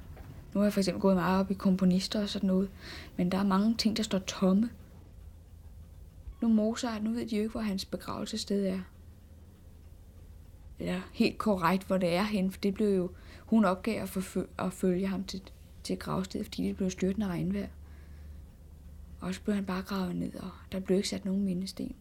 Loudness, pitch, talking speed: -31 LUFS, 190 Hz, 200 wpm